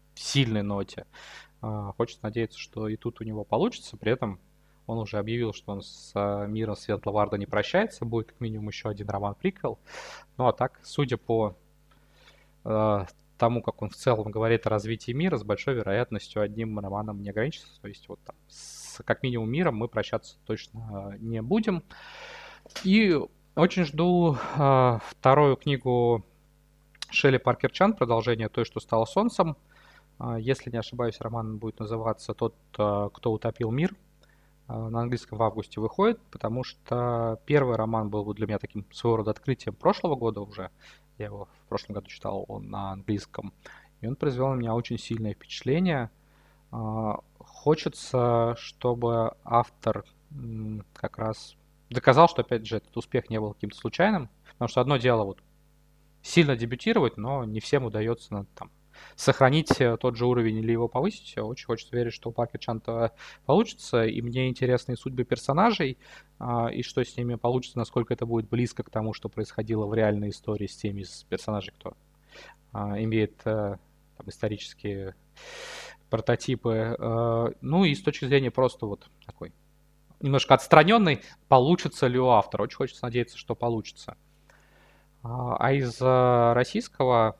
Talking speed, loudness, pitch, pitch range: 150 wpm, -27 LUFS, 120 Hz, 110-140 Hz